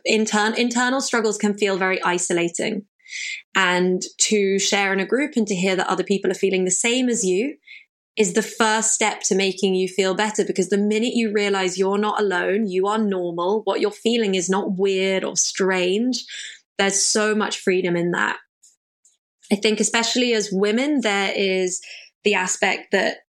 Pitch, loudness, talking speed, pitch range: 200 Hz, -20 LUFS, 180 wpm, 190-220 Hz